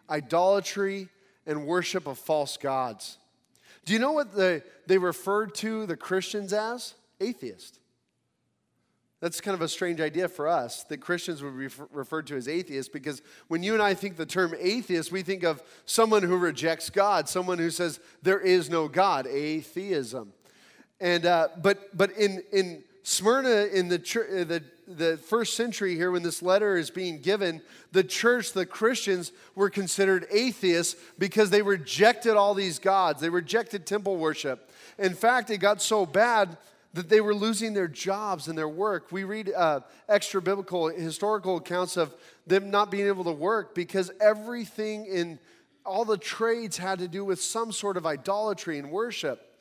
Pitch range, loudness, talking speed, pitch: 170-205 Hz, -27 LUFS, 170 wpm, 190 Hz